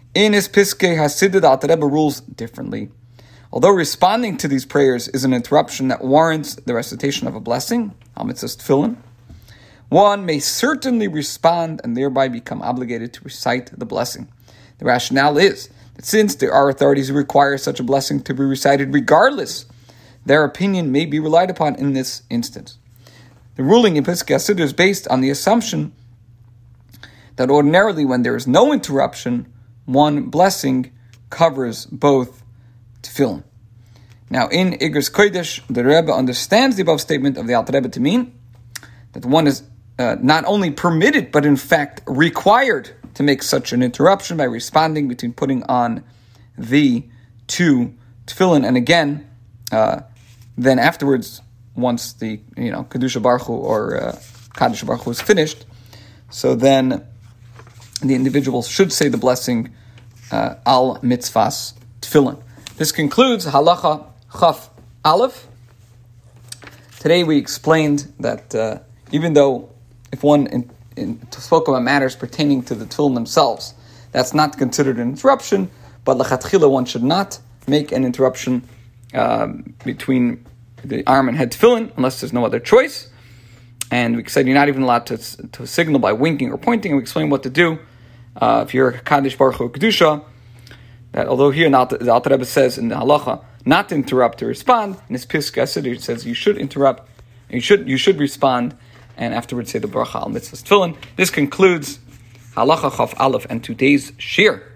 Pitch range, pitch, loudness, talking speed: 120-150 Hz, 130 Hz, -17 LUFS, 155 wpm